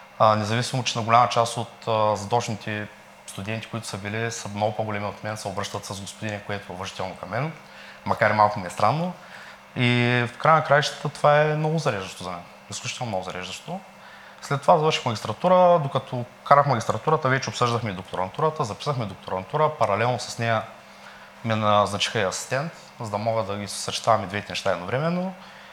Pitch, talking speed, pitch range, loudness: 110 Hz, 175 wpm, 105-130 Hz, -24 LUFS